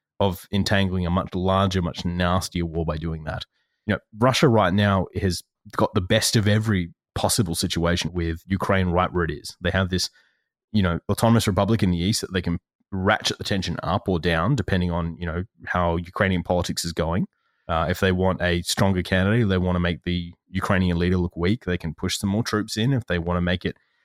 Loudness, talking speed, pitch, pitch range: -23 LUFS, 215 wpm, 95 Hz, 85-100 Hz